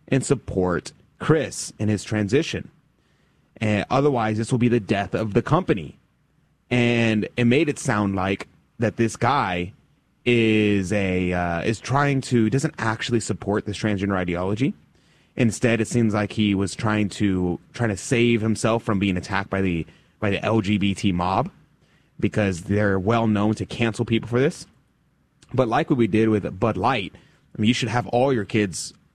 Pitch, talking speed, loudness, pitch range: 110 Hz, 170 wpm, -22 LUFS, 100-120 Hz